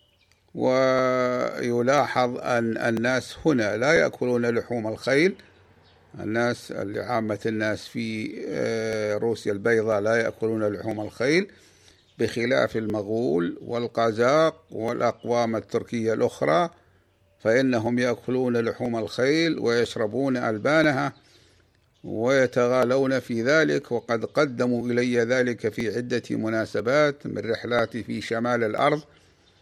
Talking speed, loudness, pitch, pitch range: 90 wpm, -24 LUFS, 115 Hz, 110-125 Hz